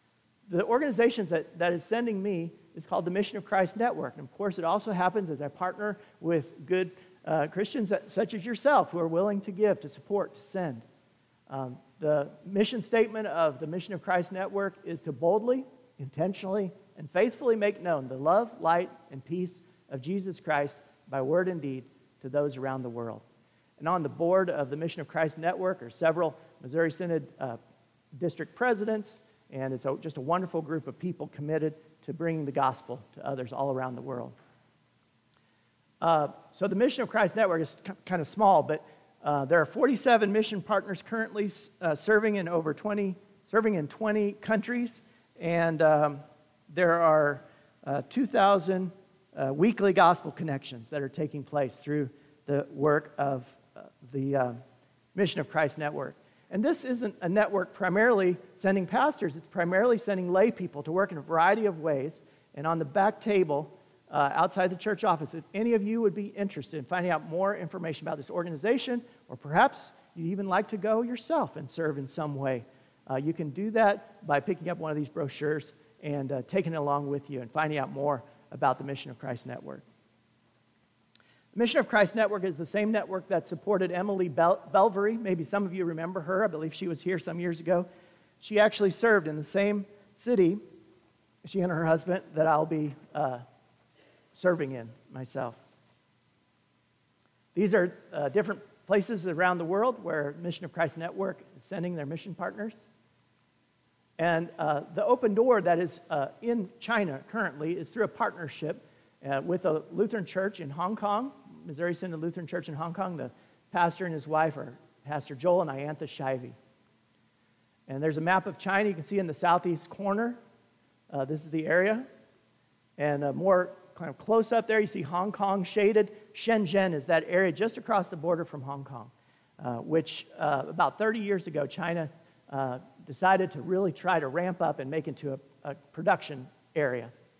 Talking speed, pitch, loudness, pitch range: 185 wpm, 170 Hz, -29 LUFS, 145-200 Hz